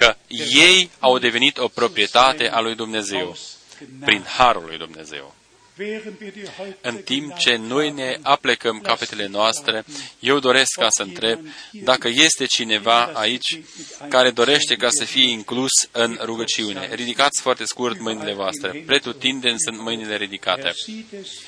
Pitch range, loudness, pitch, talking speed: 110-140 Hz, -18 LUFS, 120 Hz, 130 wpm